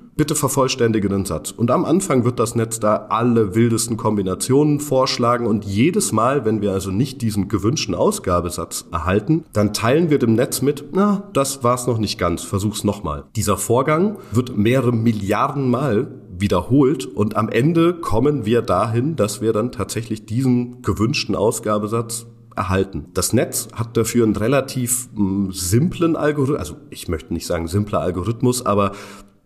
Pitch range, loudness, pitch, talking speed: 100-130 Hz, -19 LUFS, 115 Hz, 160 wpm